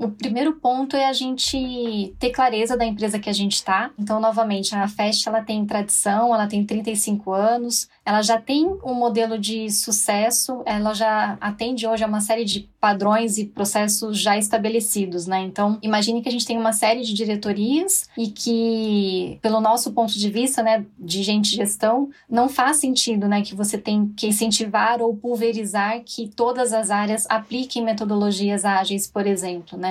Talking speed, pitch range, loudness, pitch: 180 wpm, 205-235 Hz, -21 LUFS, 220 Hz